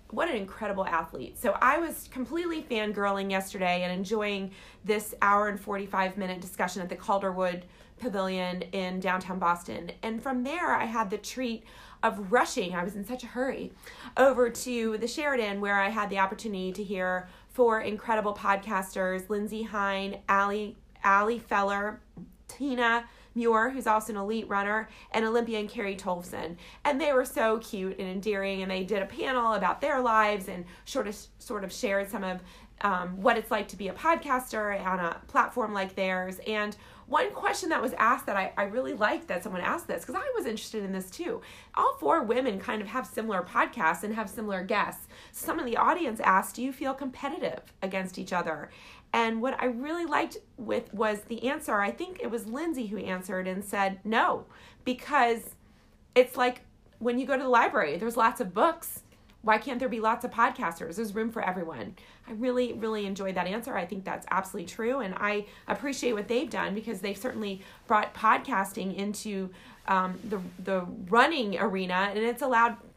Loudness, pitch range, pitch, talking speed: -29 LUFS, 195-240 Hz, 215 Hz, 185 wpm